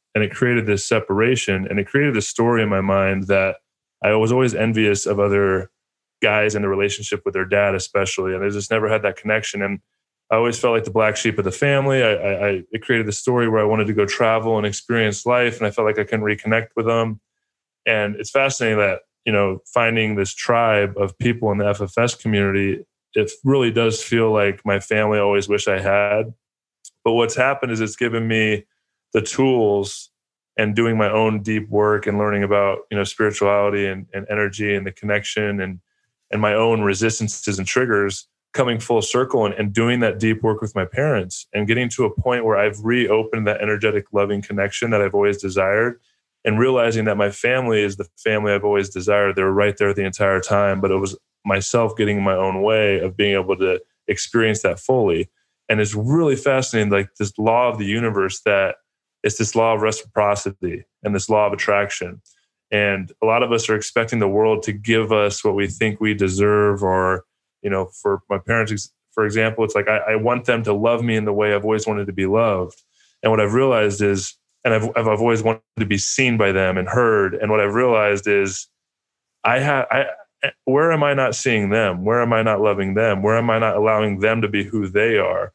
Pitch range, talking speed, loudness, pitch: 100-115 Hz, 210 wpm, -19 LUFS, 105 Hz